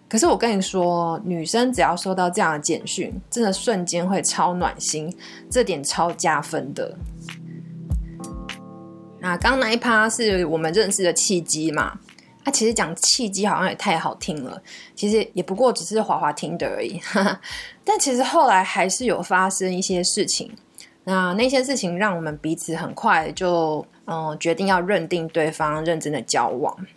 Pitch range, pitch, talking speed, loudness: 165-220 Hz, 185 Hz, 250 characters per minute, -21 LUFS